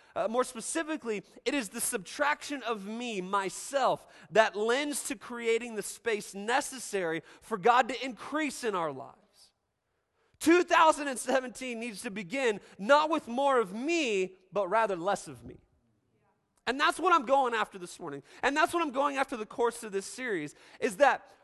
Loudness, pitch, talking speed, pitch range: -30 LUFS, 235 Hz, 165 wpm, 205-275 Hz